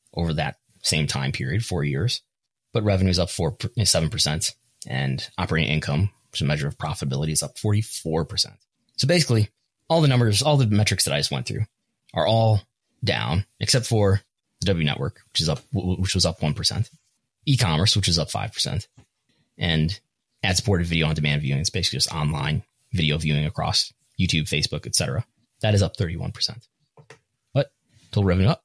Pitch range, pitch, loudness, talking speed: 80-120 Hz, 100 Hz, -23 LUFS, 185 wpm